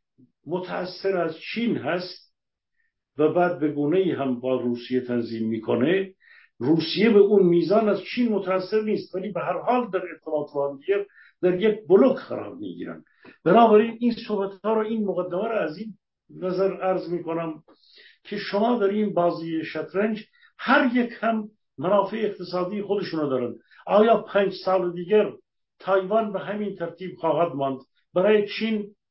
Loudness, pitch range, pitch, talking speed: -24 LUFS, 165-210 Hz, 190 Hz, 150 wpm